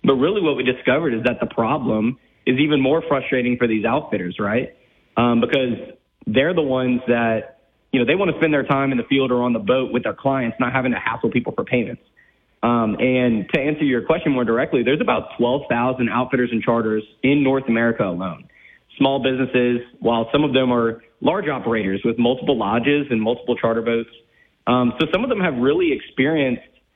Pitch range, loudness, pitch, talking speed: 115-135 Hz, -20 LUFS, 125 Hz, 200 wpm